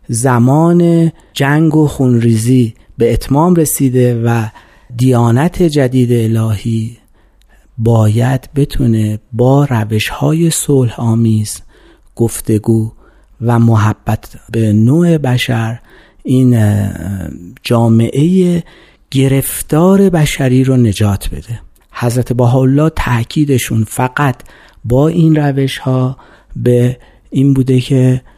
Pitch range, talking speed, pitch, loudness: 115-140 Hz, 95 wpm, 125 Hz, -12 LUFS